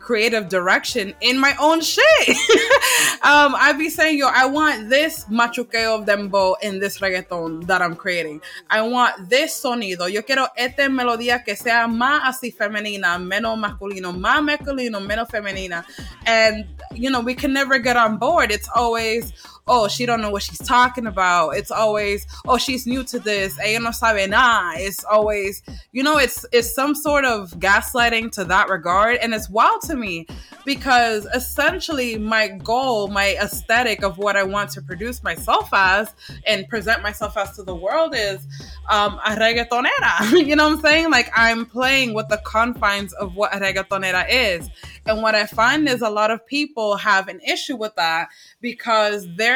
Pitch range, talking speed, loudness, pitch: 205-255 Hz, 175 wpm, -18 LUFS, 225 Hz